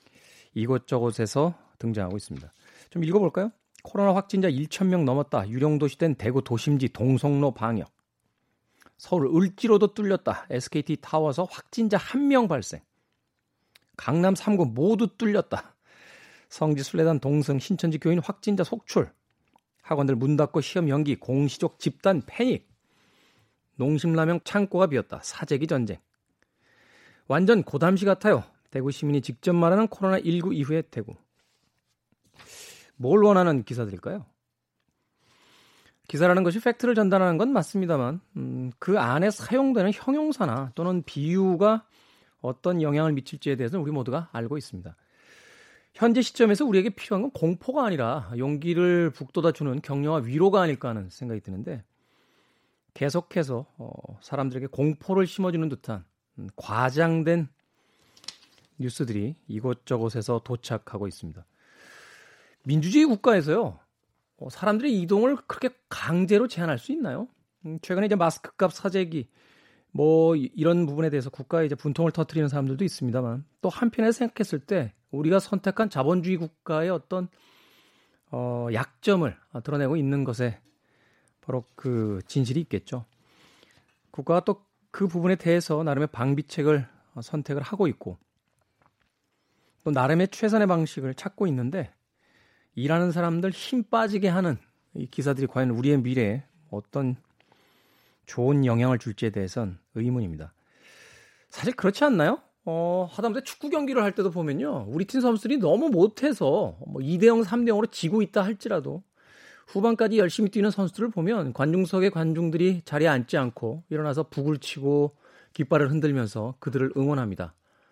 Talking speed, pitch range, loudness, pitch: 310 characters per minute, 130-195 Hz, -25 LUFS, 160 Hz